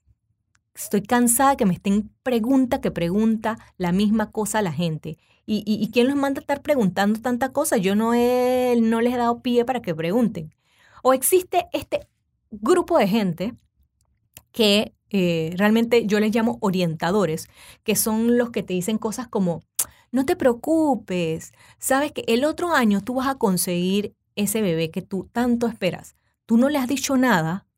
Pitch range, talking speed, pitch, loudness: 185-250 Hz, 175 wpm, 220 Hz, -22 LUFS